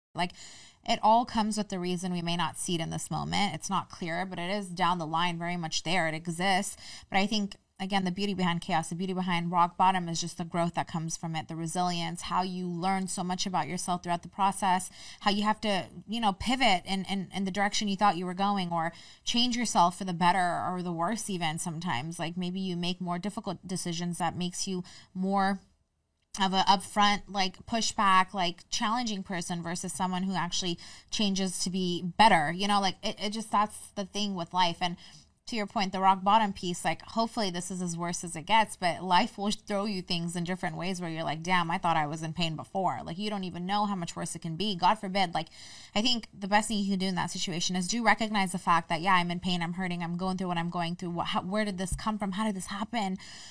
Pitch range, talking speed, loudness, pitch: 175-200 Hz, 245 wpm, -30 LUFS, 185 Hz